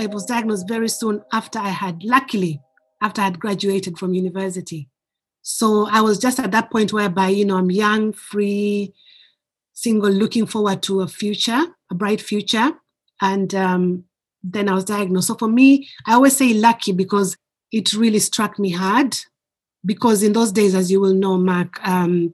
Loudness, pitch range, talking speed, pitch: -18 LUFS, 190-220 Hz, 175 wpm, 205 Hz